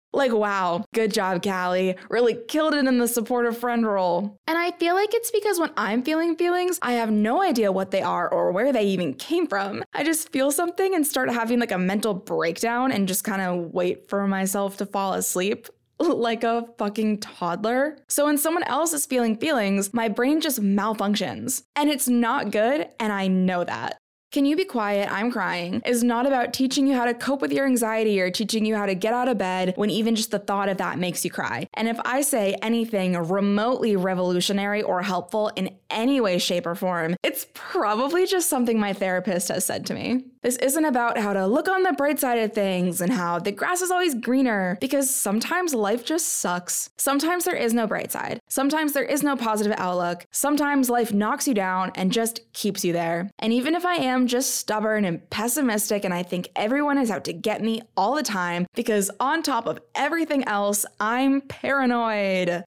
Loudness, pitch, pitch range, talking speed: -23 LUFS, 225 Hz, 195-275 Hz, 205 wpm